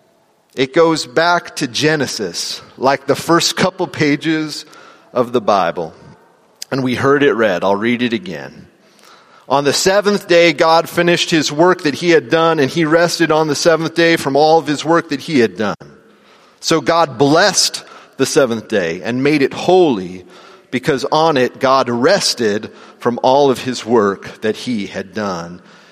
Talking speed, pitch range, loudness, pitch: 170 wpm, 130-165 Hz, -14 LUFS, 155 Hz